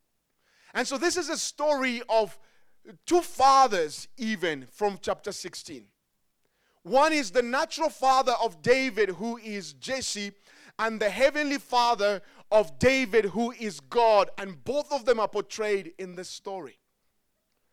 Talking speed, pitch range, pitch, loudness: 140 wpm, 200-265 Hz, 230 Hz, -26 LUFS